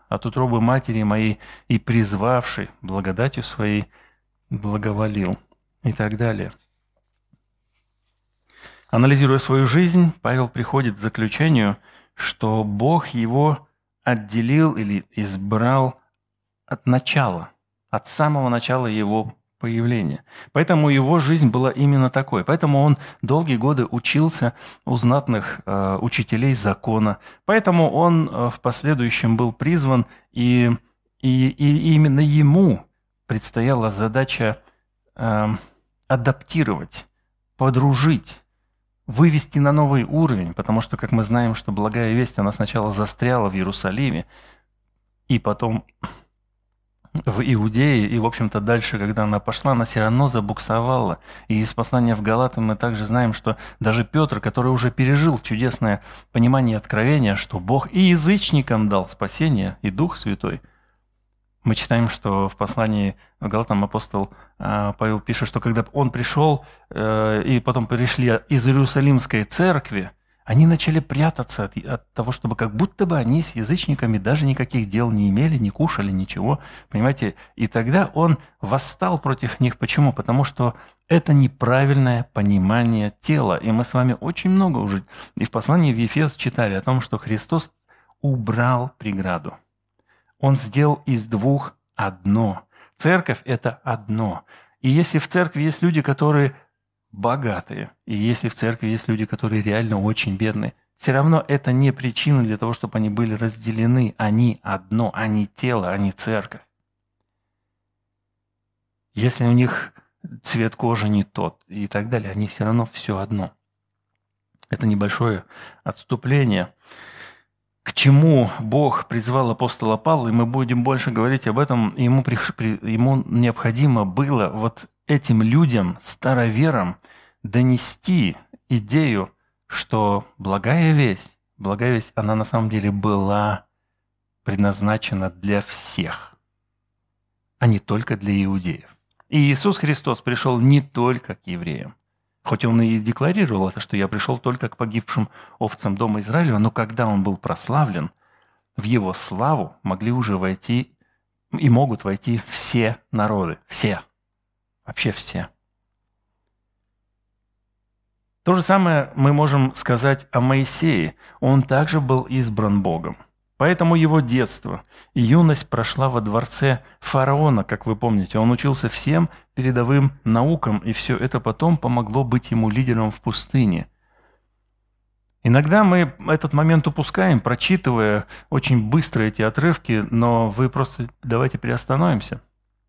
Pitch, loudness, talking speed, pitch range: 120 Hz, -20 LUFS, 130 wpm, 105-135 Hz